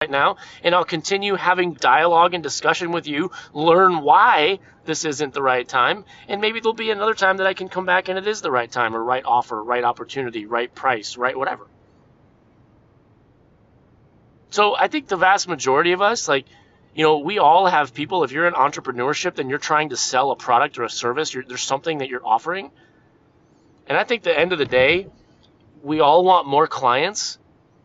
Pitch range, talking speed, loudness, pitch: 135-190 Hz, 195 wpm, -19 LUFS, 170 Hz